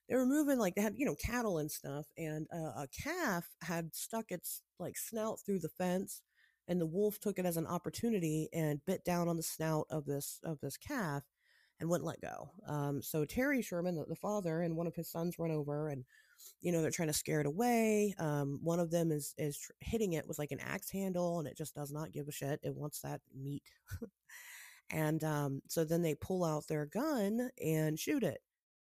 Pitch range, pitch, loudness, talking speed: 150-185 Hz, 165 Hz, -38 LUFS, 225 wpm